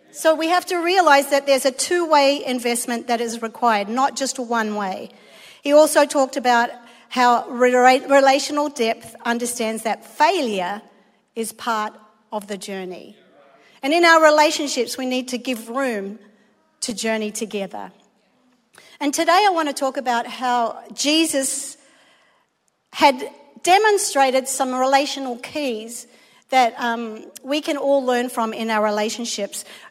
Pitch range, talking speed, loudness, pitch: 230-280 Hz, 140 wpm, -19 LUFS, 255 Hz